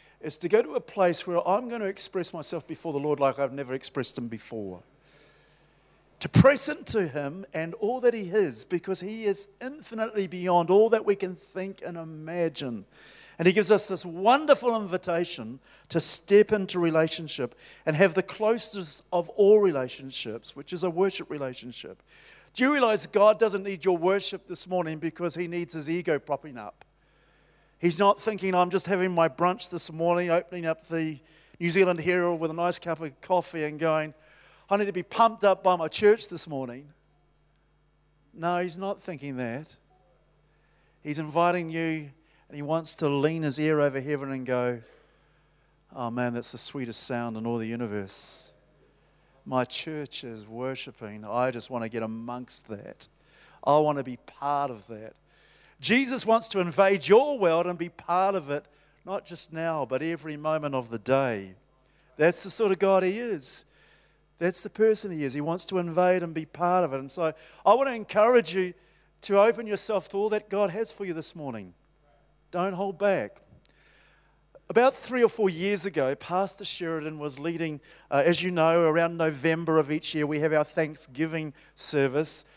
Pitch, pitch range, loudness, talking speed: 170 Hz, 145-195 Hz, -26 LUFS, 180 wpm